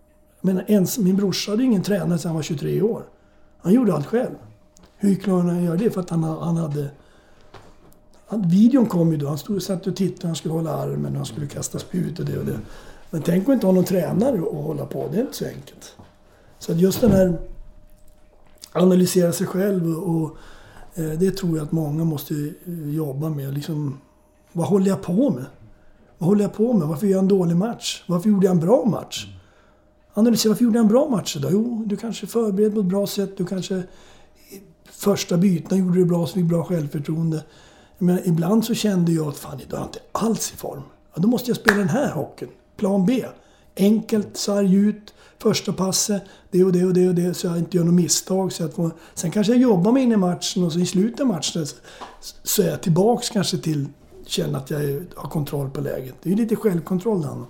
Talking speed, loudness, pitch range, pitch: 220 wpm, -21 LUFS, 160-200 Hz, 180 Hz